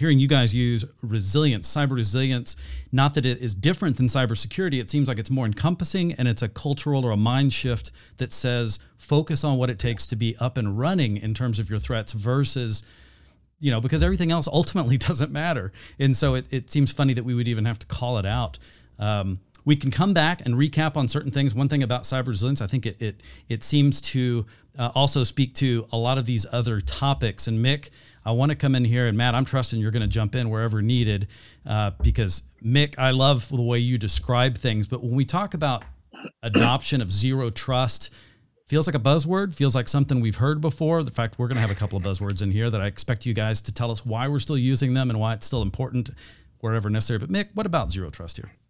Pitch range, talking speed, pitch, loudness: 110-140 Hz, 230 wpm, 125 Hz, -24 LUFS